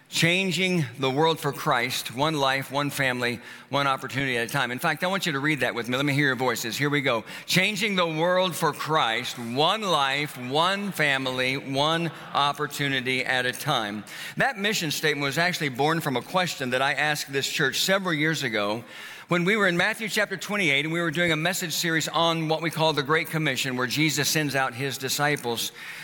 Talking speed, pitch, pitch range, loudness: 205 wpm, 150 Hz, 135-165 Hz, -24 LUFS